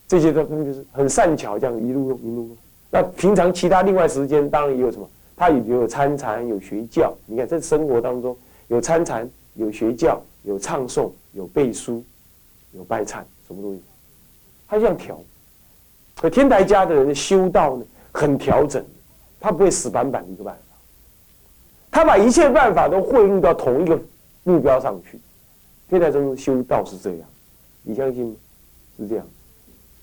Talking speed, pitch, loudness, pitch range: 245 characters per minute, 135 Hz, -19 LUFS, 115-160 Hz